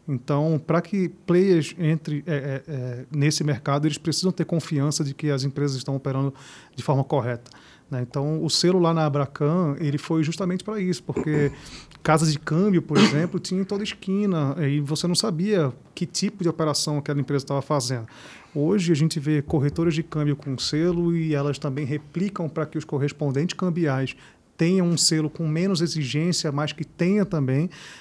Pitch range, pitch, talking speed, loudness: 145-170 Hz, 155 Hz, 180 wpm, -24 LUFS